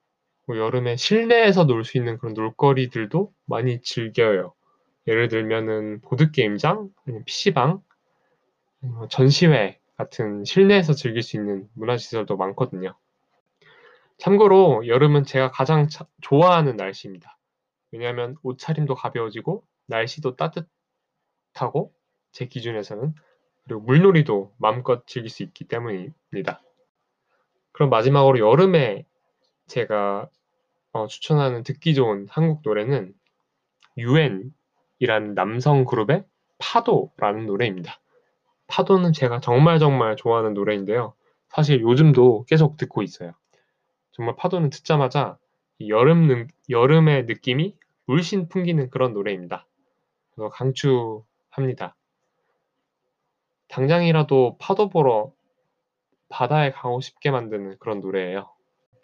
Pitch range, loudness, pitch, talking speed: 115-155 Hz, -21 LUFS, 130 Hz, 265 characters per minute